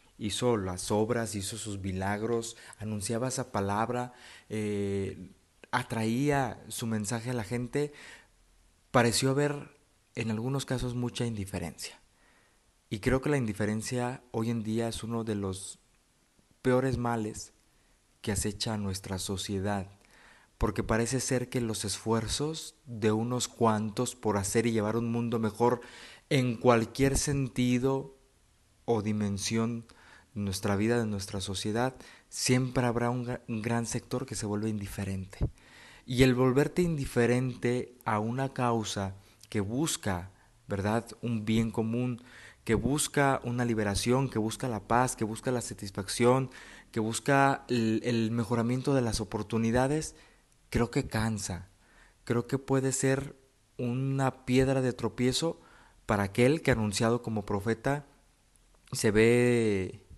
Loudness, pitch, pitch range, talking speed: -30 LUFS, 115 Hz, 105-125 Hz, 130 wpm